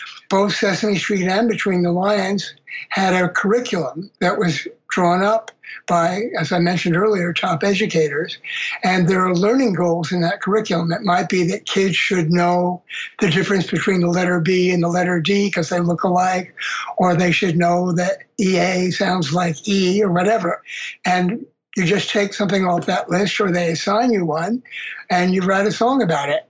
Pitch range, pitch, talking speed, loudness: 175-205 Hz, 185 Hz, 185 wpm, -18 LUFS